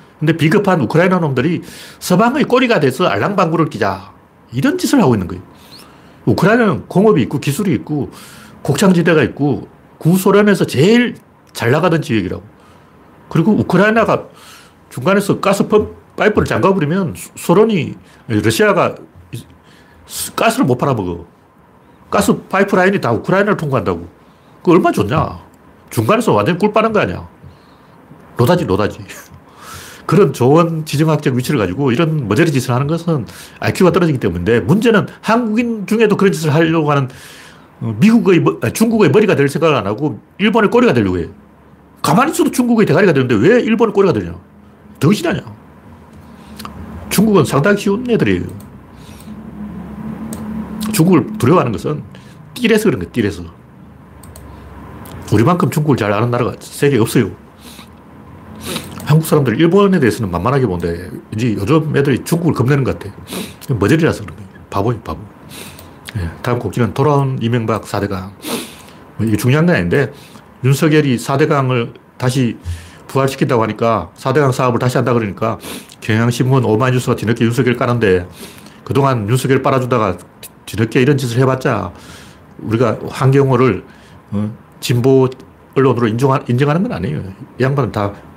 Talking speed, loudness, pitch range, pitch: 335 characters per minute, -14 LUFS, 115-185 Hz, 140 Hz